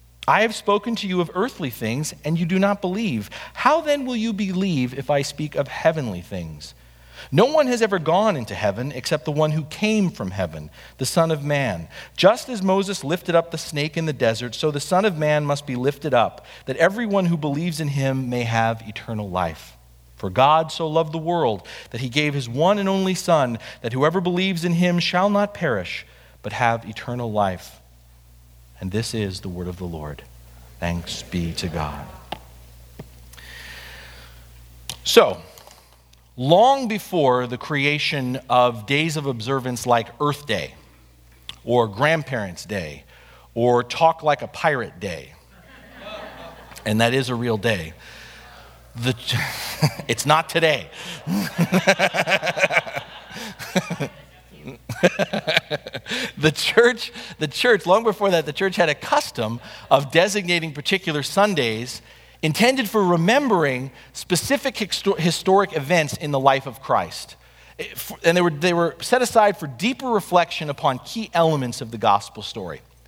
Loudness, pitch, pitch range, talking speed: -21 LUFS, 145 Hz, 105-175 Hz, 150 wpm